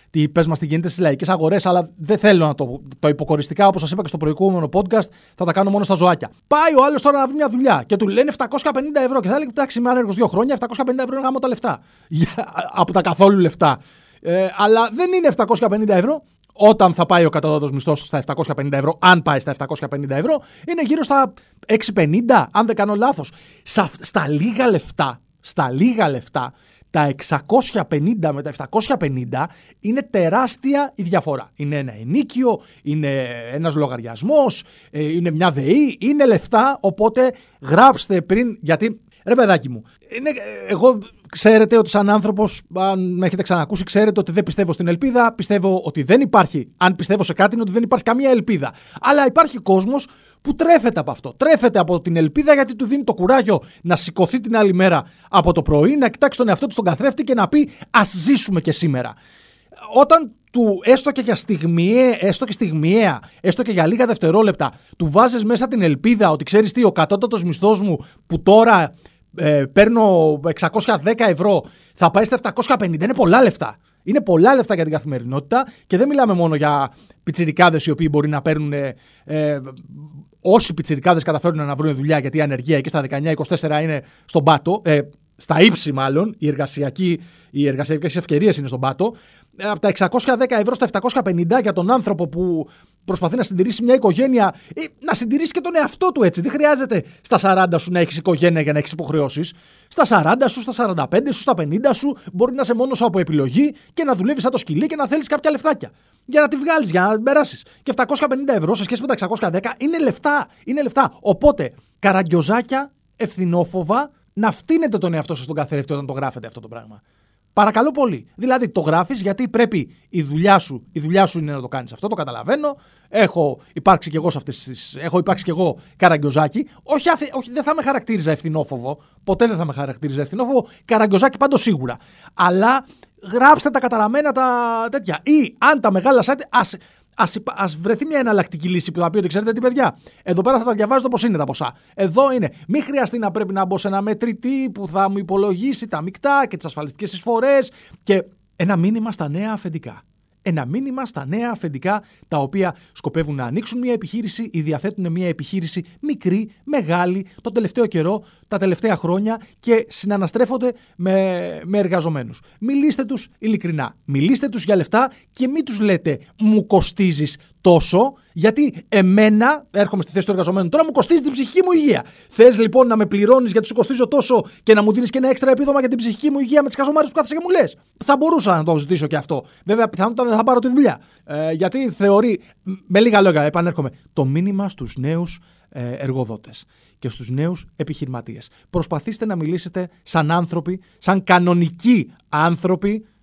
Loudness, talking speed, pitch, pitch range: -17 LUFS, 185 wpm, 195 Hz, 165-245 Hz